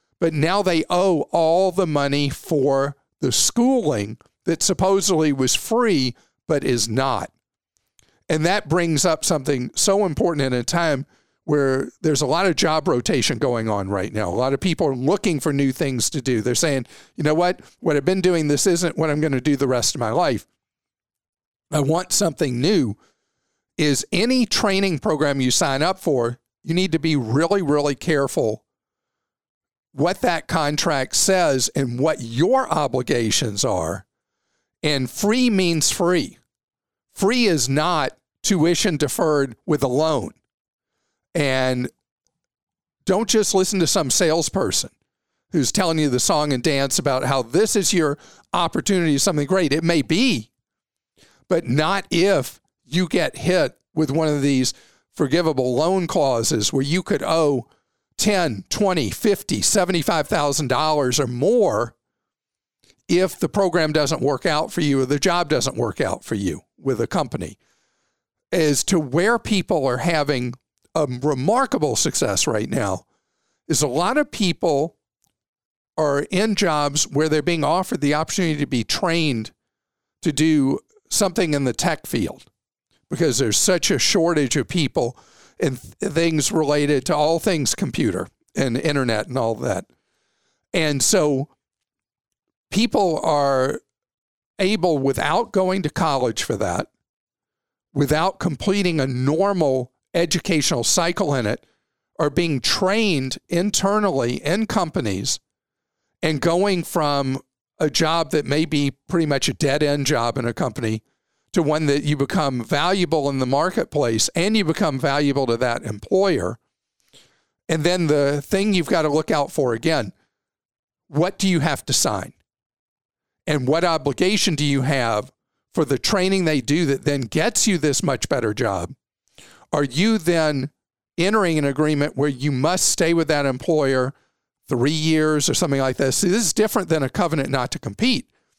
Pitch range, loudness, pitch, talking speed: 135-180 Hz, -20 LUFS, 155 Hz, 155 wpm